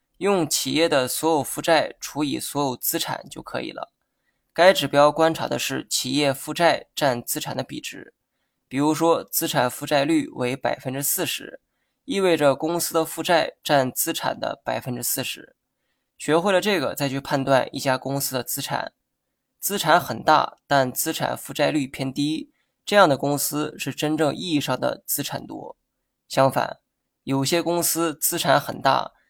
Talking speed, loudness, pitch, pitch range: 245 characters per minute, -22 LUFS, 145 Hz, 135-165 Hz